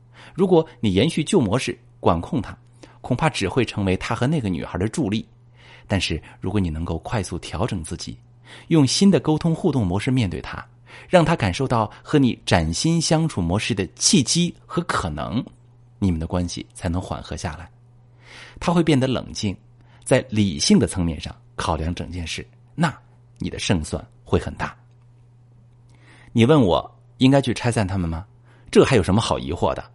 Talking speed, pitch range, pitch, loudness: 255 characters per minute, 95-125 Hz, 120 Hz, -21 LUFS